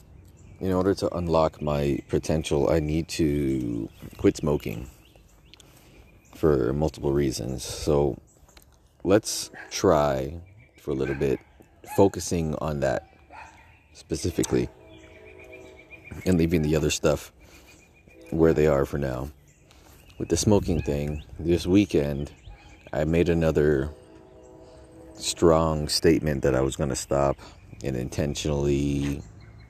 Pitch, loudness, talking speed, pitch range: 75 Hz, -25 LUFS, 110 wpm, 70-85 Hz